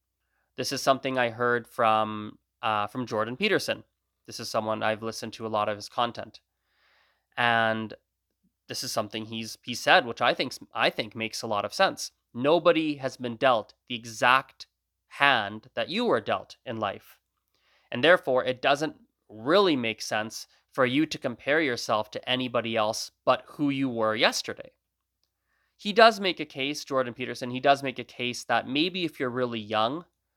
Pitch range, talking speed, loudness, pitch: 110-135 Hz, 175 wpm, -27 LUFS, 120 Hz